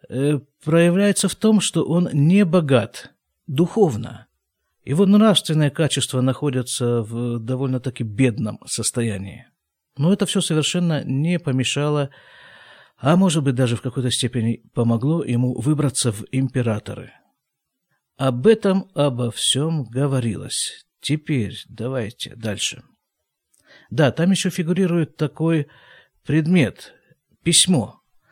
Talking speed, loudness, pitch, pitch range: 105 wpm, -20 LUFS, 140 Hz, 125-165 Hz